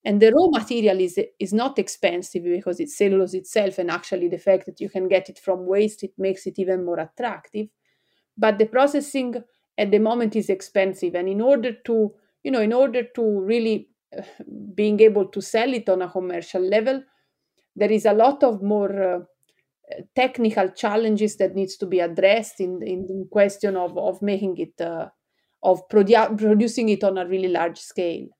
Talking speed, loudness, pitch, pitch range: 185 wpm, -22 LUFS, 200 Hz, 185-225 Hz